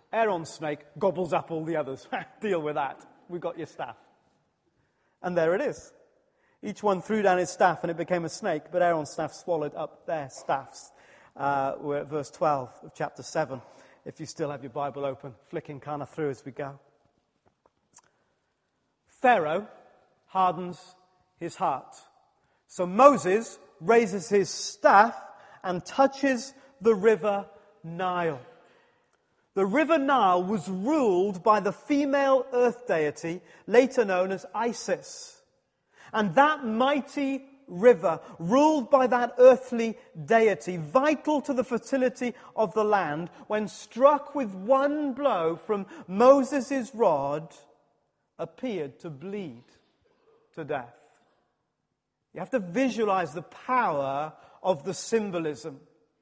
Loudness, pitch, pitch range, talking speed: -26 LUFS, 195 Hz, 160-255 Hz, 130 wpm